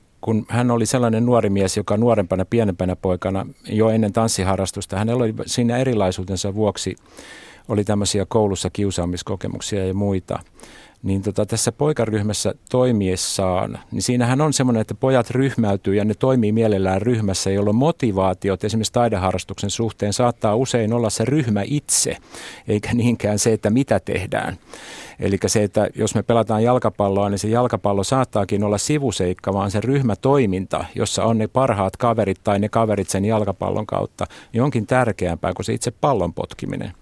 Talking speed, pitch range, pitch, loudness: 150 wpm, 100-120 Hz, 105 Hz, -20 LUFS